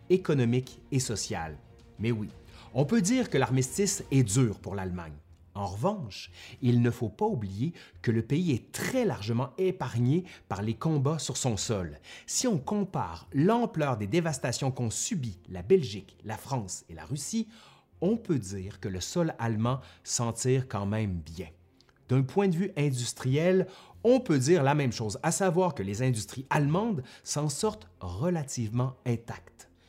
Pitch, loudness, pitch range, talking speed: 130 Hz, -29 LUFS, 105-160 Hz, 165 wpm